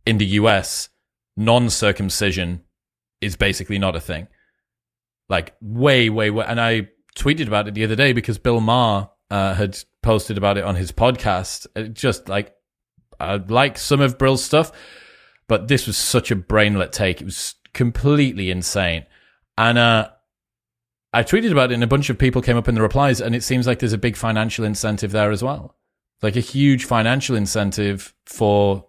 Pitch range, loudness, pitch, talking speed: 100-120 Hz, -19 LUFS, 110 Hz, 180 wpm